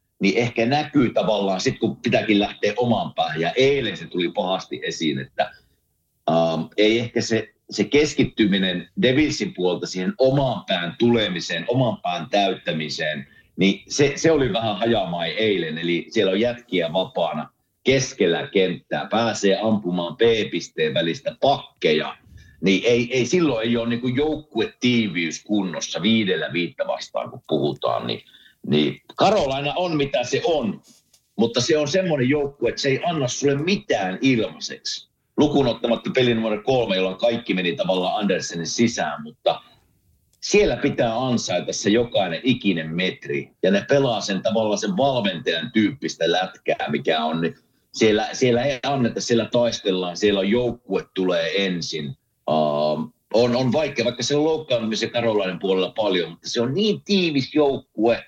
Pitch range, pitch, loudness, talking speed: 95-130 Hz, 115 Hz, -22 LUFS, 145 wpm